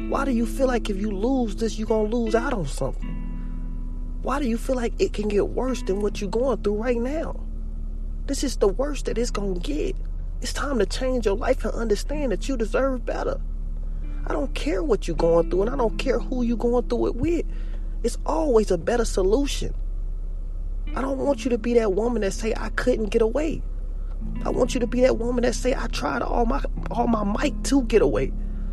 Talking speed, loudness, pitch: 225 wpm, -25 LUFS, 225 Hz